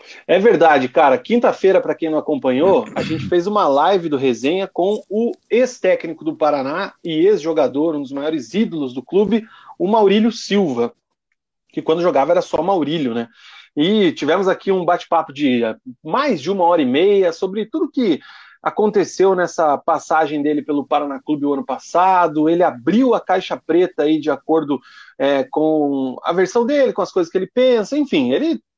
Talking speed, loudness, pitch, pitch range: 175 wpm, -17 LUFS, 170 Hz, 150-205 Hz